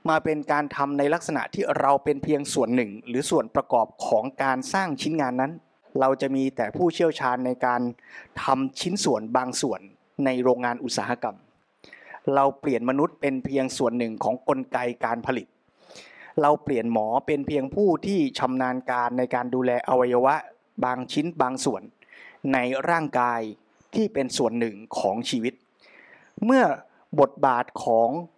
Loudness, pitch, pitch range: -25 LUFS, 135 Hz, 125-150 Hz